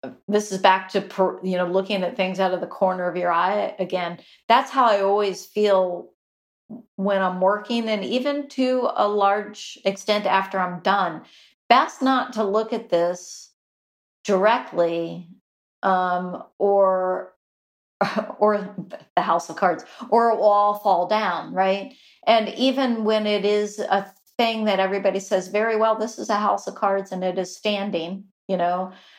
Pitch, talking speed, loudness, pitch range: 195 Hz, 160 wpm, -22 LUFS, 185-215 Hz